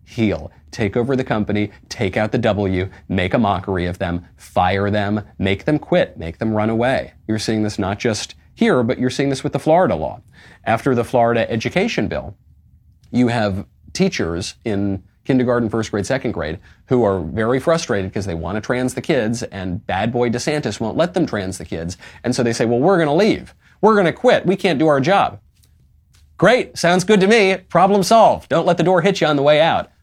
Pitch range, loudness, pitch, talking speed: 100-135 Hz, -18 LUFS, 115 Hz, 215 wpm